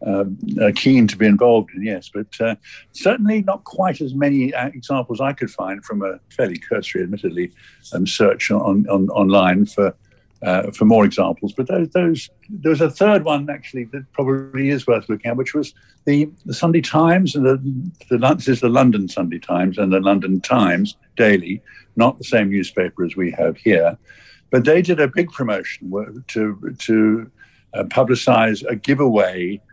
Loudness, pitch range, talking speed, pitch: -18 LUFS, 105-150 Hz, 180 wpm, 130 Hz